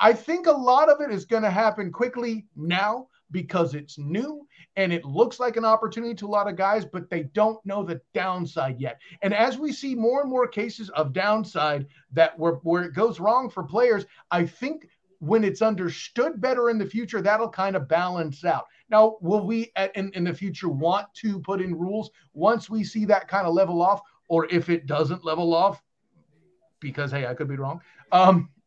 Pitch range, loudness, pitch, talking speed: 170-220 Hz, -24 LUFS, 195 Hz, 205 wpm